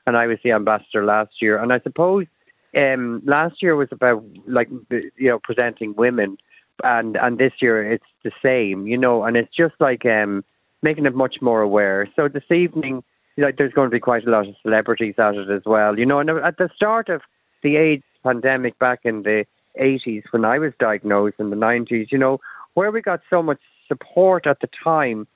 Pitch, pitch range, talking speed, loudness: 120 Hz, 110-145 Hz, 215 wpm, -19 LUFS